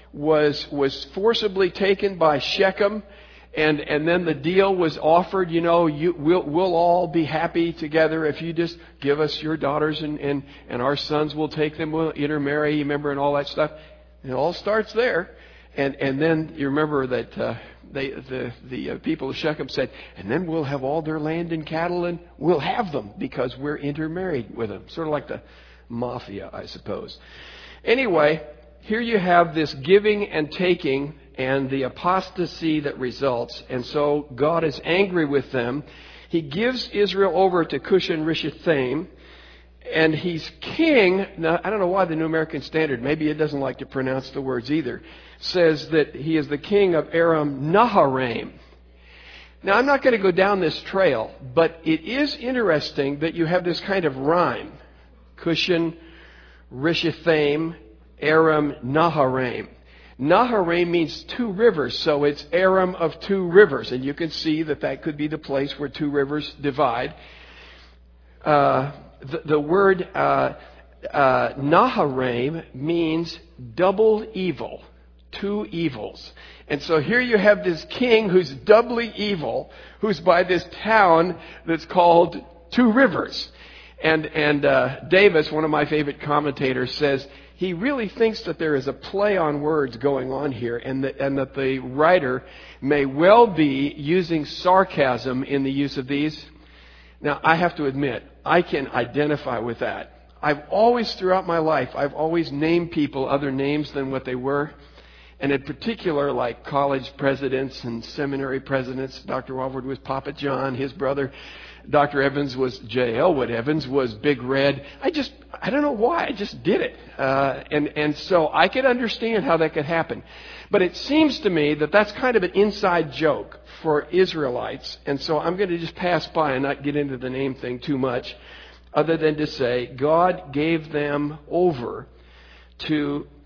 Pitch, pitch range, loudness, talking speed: 155 Hz, 135-175 Hz, -22 LUFS, 170 wpm